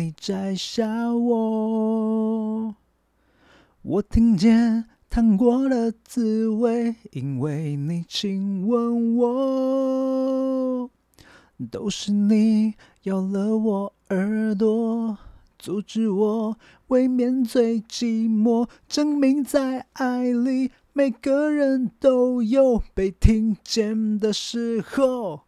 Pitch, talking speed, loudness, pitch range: 230 Hz, 115 characters per minute, -22 LUFS, 215-250 Hz